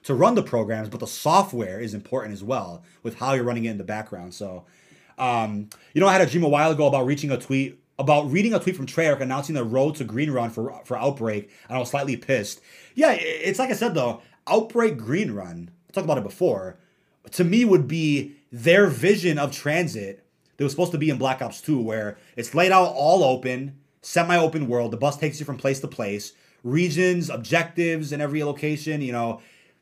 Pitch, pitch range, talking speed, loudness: 140 Hz, 115-165 Hz, 215 wpm, -23 LUFS